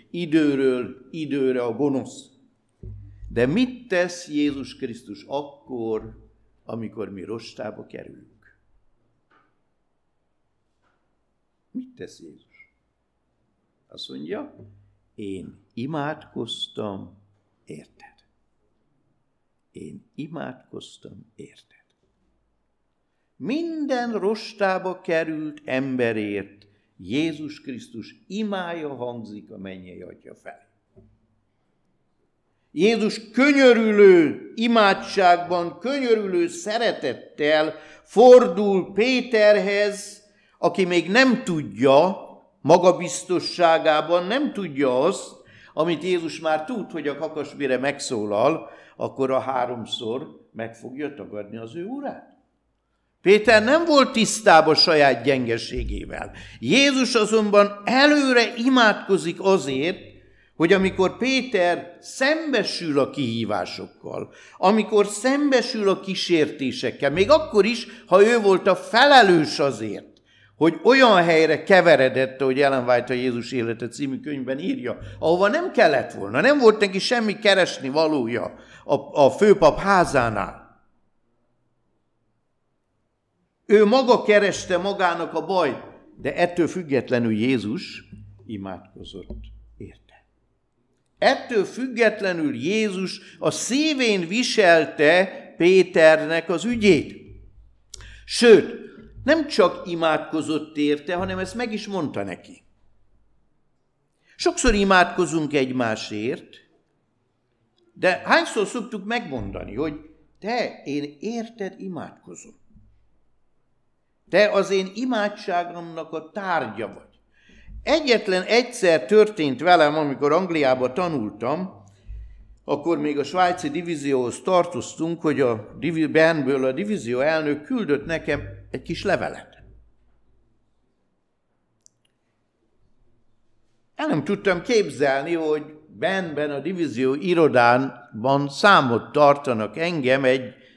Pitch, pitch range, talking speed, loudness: 160 Hz, 125-205 Hz, 90 wpm, -20 LUFS